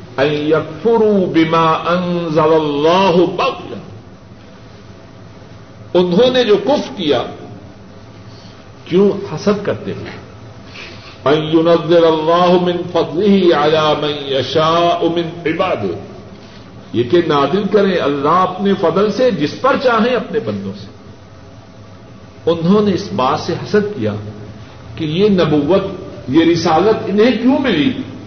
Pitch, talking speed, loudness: 160 Hz, 105 wpm, -14 LUFS